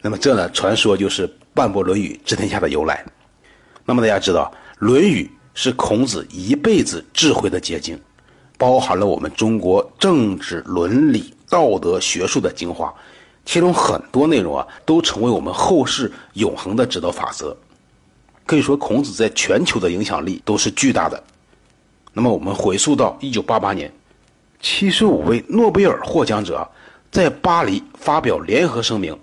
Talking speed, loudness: 240 characters per minute, -18 LUFS